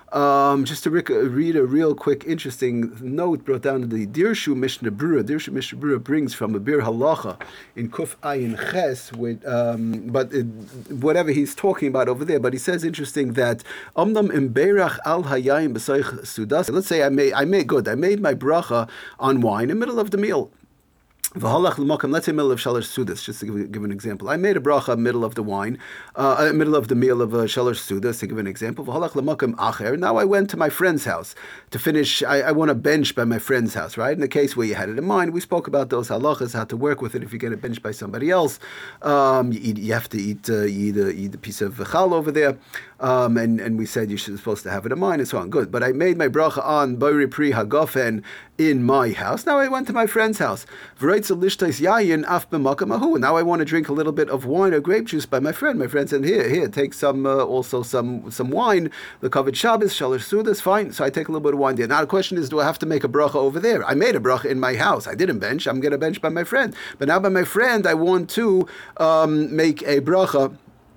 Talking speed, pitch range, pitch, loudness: 240 wpm, 120-160 Hz, 140 Hz, -21 LUFS